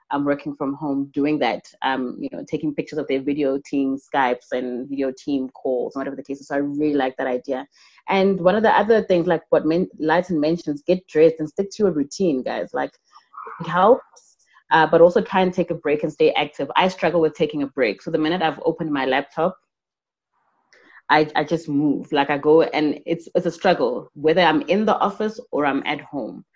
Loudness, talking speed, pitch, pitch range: -21 LUFS, 220 wpm, 155 Hz, 140-175 Hz